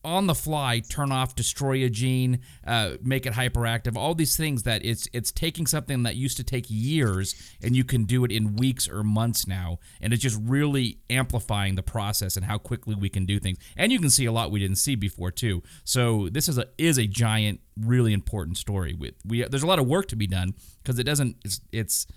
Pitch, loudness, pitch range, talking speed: 115 Hz, -25 LUFS, 100-130 Hz, 235 wpm